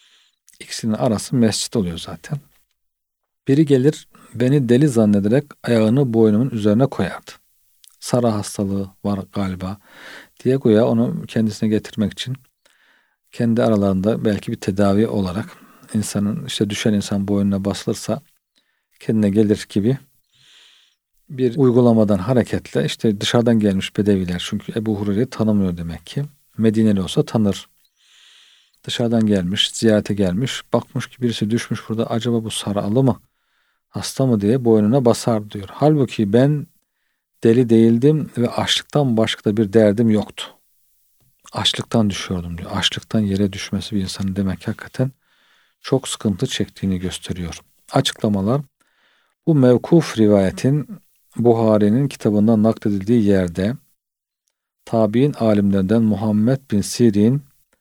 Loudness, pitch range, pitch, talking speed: -18 LUFS, 100-125 Hz, 110 Hz, 115 wpm